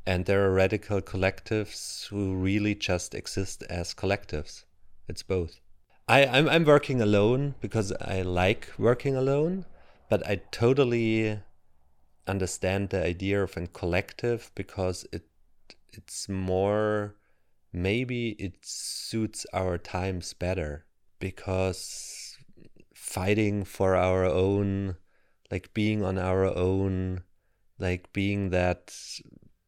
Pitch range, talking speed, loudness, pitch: 90-105 Hz, 110 wpm, -28 LUFS, 95 Hz